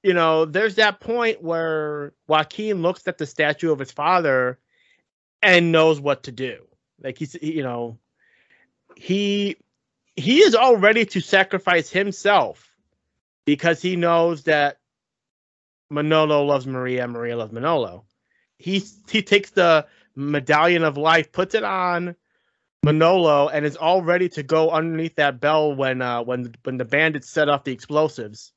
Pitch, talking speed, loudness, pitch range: 160 Hz, 155 wpm, -20 LUFS, 140-180 Hz